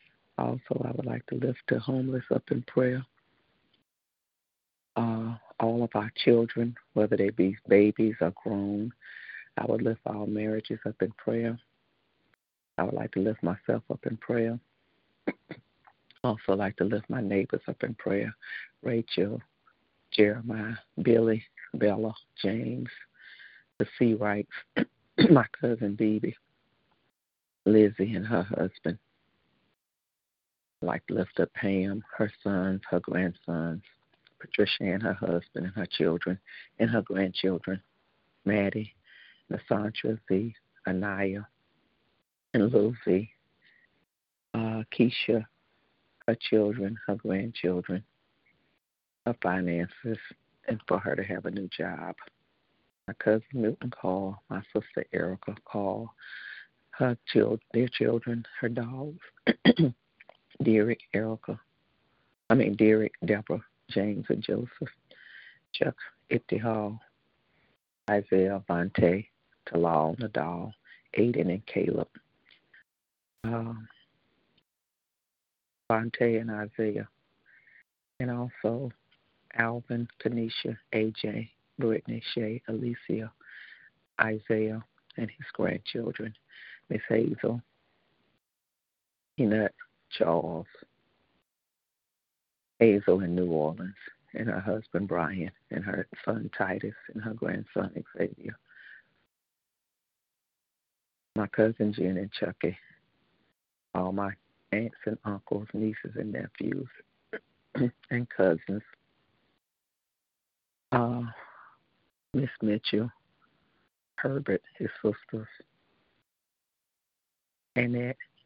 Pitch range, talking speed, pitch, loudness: 95-115 Hz, 100 wpm, 110 Hz, -30 LUFS